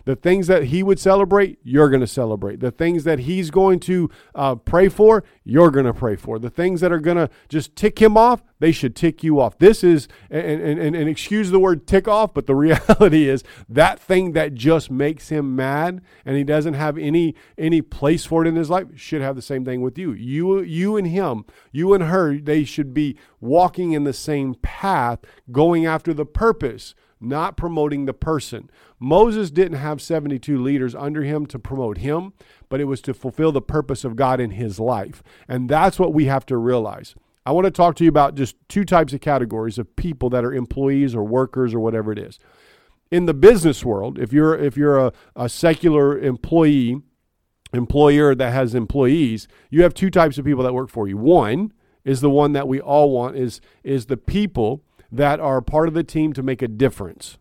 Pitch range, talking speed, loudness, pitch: 130-170 Hz, 210 wpm, -18 LUFS, 145 Hz